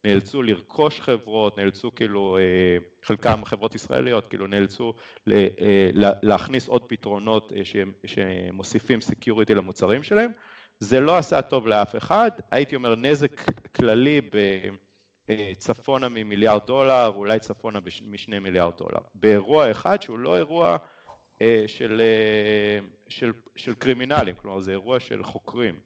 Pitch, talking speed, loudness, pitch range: 110 Hz, 115 wpm, -15 LUFS, 100-120 Hz